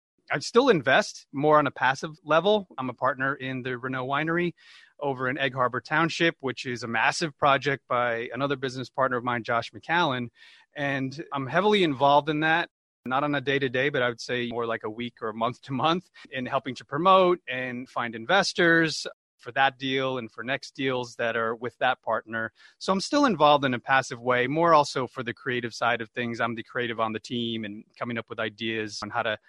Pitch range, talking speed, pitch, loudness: 120-145 Hz, 220 wpm, 130 Hz, -26 LUFS